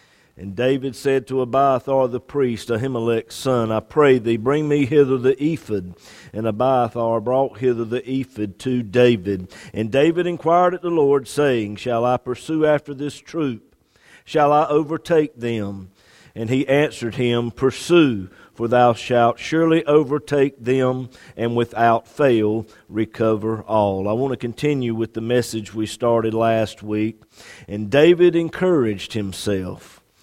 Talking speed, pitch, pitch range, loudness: 145 wpm, 125 Hz, 110-140 Hz, -20 LUFS